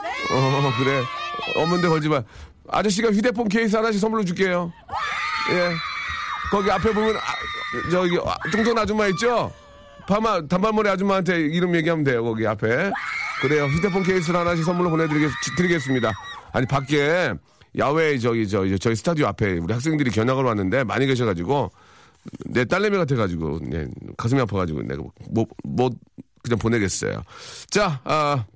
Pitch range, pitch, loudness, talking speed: 120-190 Hz, 150 Hz, -22 LUFS, 350 characters per minute